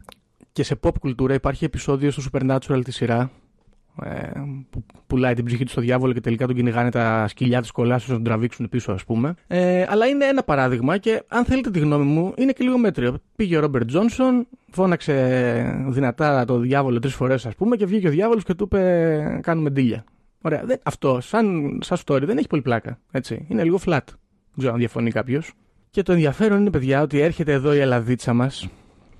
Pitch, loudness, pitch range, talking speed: 135 Hz, -21 LUFS, 125-175 Hz, 195 wpm